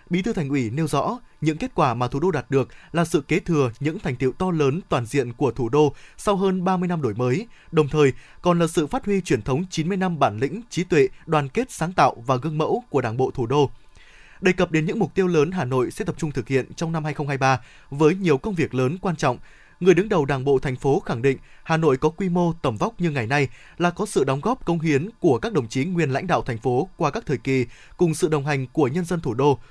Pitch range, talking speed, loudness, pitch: 135-175 Hz, 270 wpm, -23 LUFS, 155 Hz